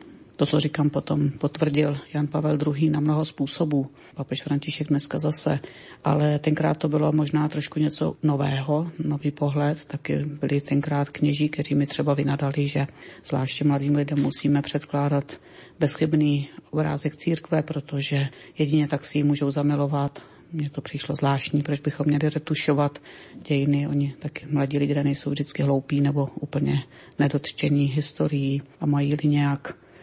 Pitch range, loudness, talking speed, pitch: 140-150 Hz, -25 LUFS, 145 wpm, 145 Hz